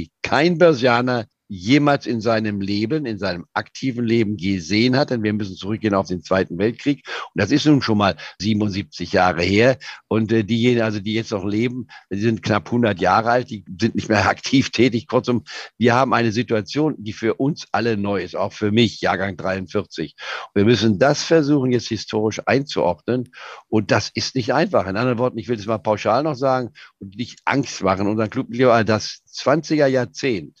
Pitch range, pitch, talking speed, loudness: 105-125 Hz, 115 Hz, 190 wpm, -20 LUFS